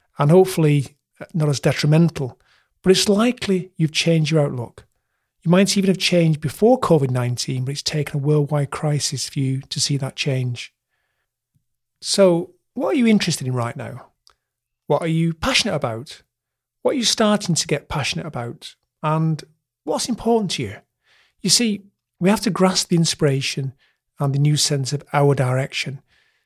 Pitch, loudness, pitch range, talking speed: 150 Hz, -19 LUFS, 135-180 Hz, 165 wpm